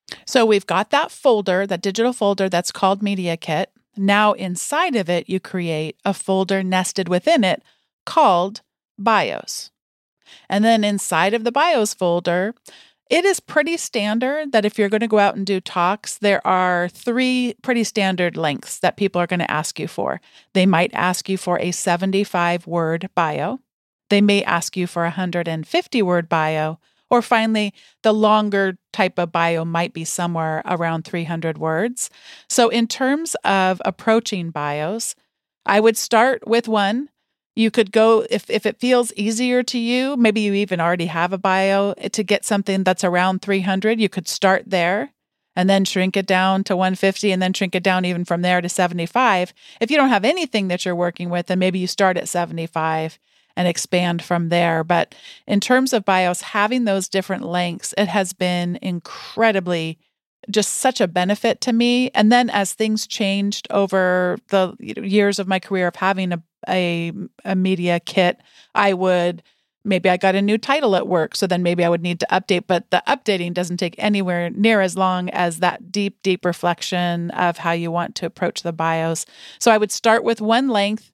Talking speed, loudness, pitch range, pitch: 190 wpm, -19 LUFS, 175-215 Hz, 190 Hz